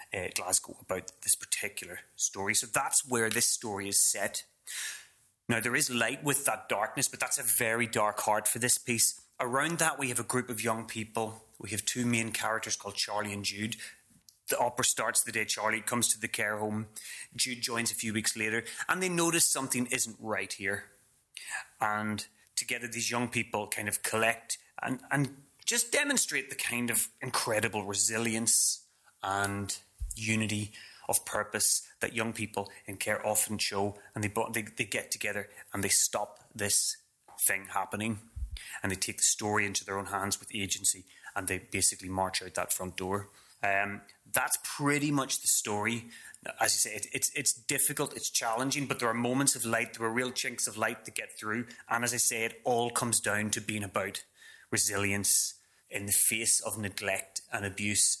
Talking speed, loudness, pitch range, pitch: 185 wpm, -29 LUFS, 105-120 Hz, 110 Hz